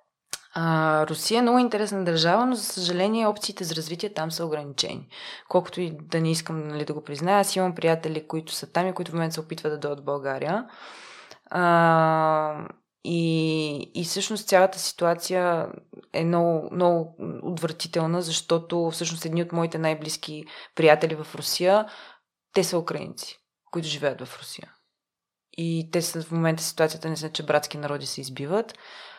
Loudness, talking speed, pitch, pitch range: -25 LUFS, 160 wpm, 165 Hz, 155-180 Hz